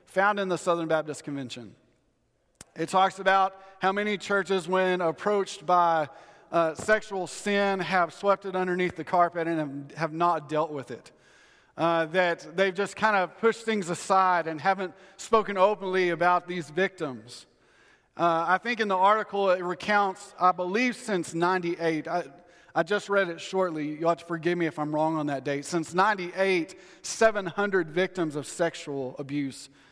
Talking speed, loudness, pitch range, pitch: 165 wpm, -27 LUFS, 165-195 Hz, 180 Hz